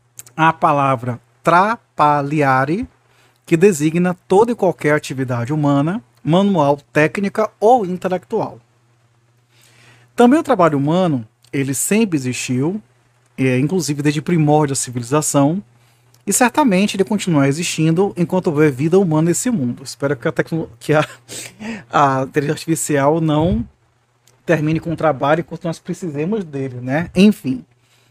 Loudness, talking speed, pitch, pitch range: -17 LUFS, 120 wpm, 150 Hz, 130-175 Hz